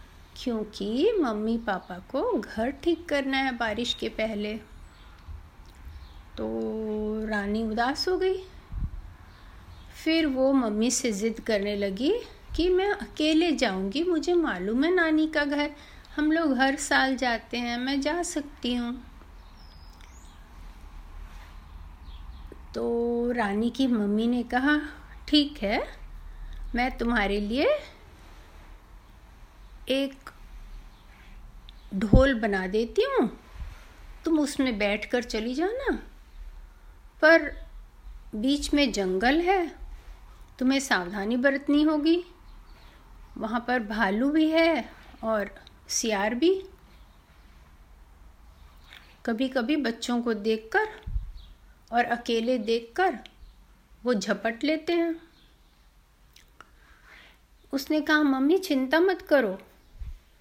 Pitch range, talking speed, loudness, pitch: 200-295 Hz, 100 wpm, -26 LUFS, 240 Hz